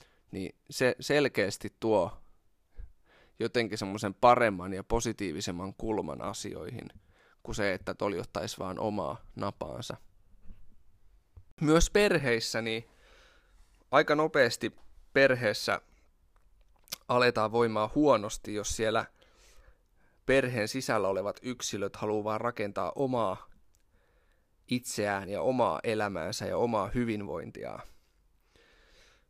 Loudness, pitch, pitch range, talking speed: -30 LUFS, 105 Hz, 95-120 Hz, 90 wpm